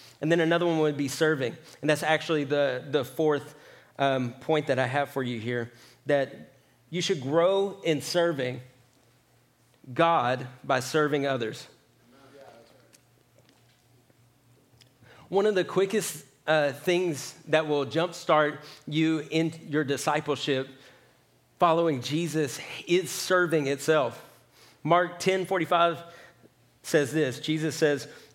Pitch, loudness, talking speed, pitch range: 150 Hz, -27 LUFS, 120 wpm, 130-165 Hz